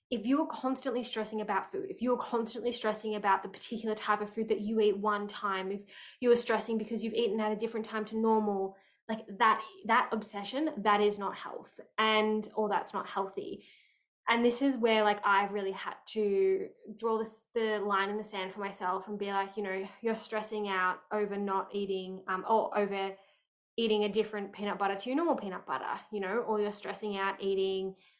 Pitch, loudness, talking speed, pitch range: 215 Hz, -32 LUFS, 210 wpm, 200-225 Hz